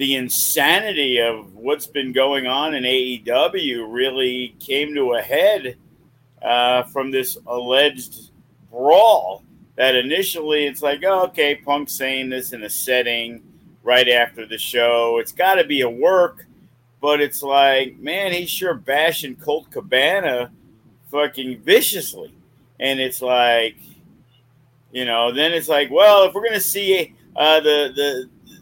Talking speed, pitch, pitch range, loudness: 140 wpm, 135 Hz, 125-150 Hz, -18 LUFS